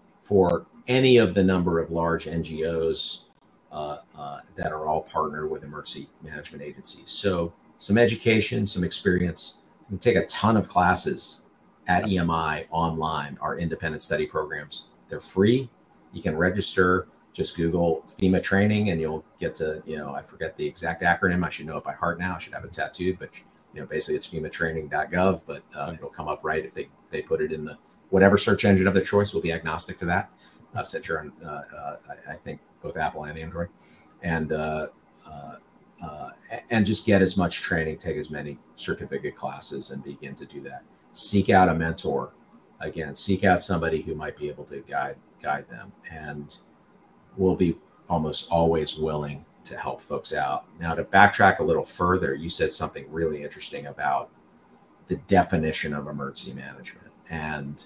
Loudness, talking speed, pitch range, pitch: -25 LUFS, 175 wpm, 80-95 Hz, 85 Hz